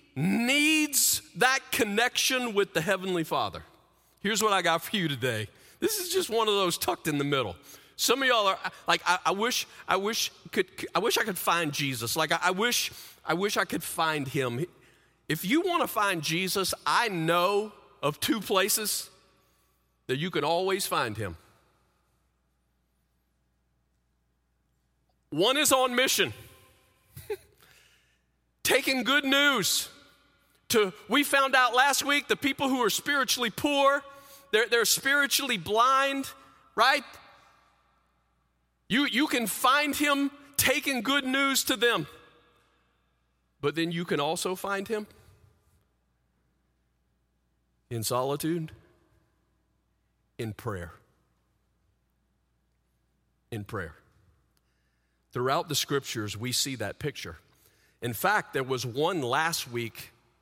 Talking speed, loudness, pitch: 130 wpm, -26 LUFS, 155 Hz